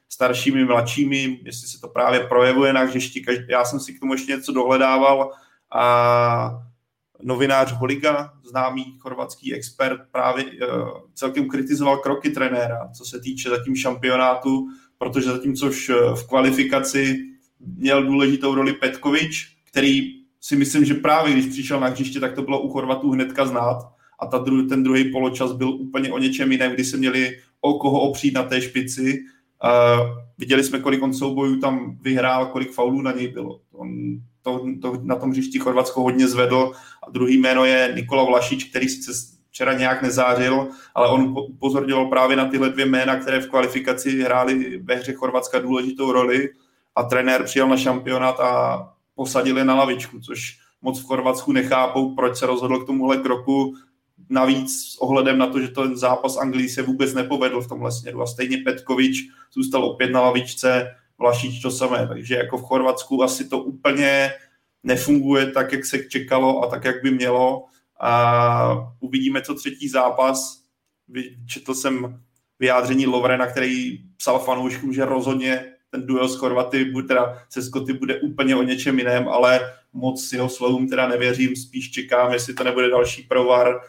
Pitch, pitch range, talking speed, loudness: 130 Hz, 125-135 Hz, 165 wpm, -20 LUFS